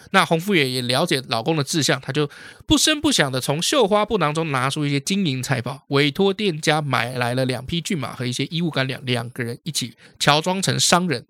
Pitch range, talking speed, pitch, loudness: 130-175 Hz, 325 characters per minute, 145 Hz, -20 LUFS